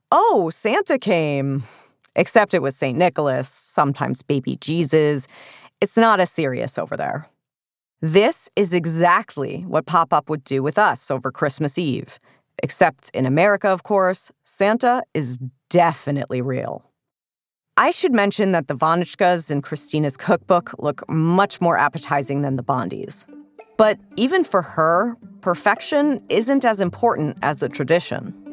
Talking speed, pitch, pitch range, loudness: 140 wpm, 170 Hz, 145-205 Hz, -20 LUFS